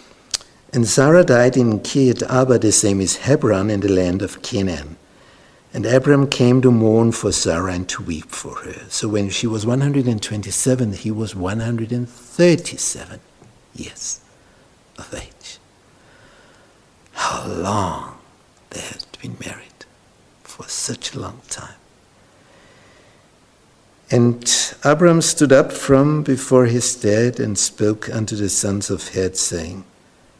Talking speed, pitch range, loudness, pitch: 130 wpm, 100-130 Hz, -17 LUFS, 115 Hz